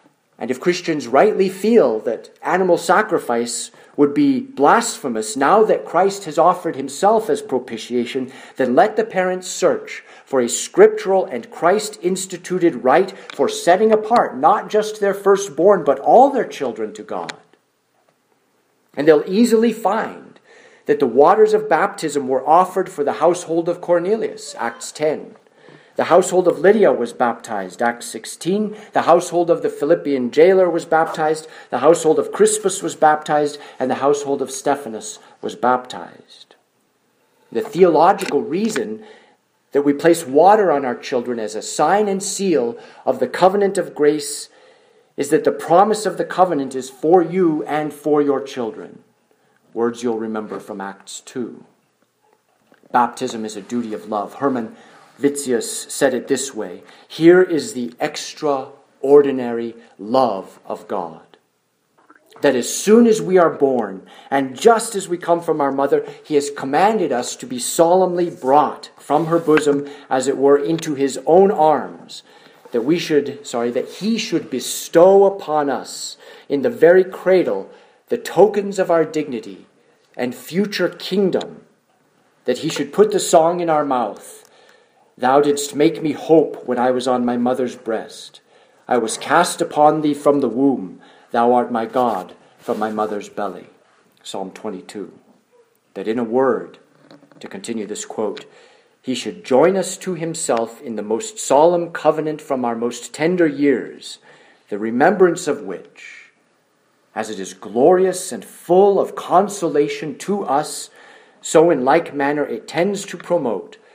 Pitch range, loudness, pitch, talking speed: 135-195 Hz, -18 LUFS, 160 Hz, 150 wpm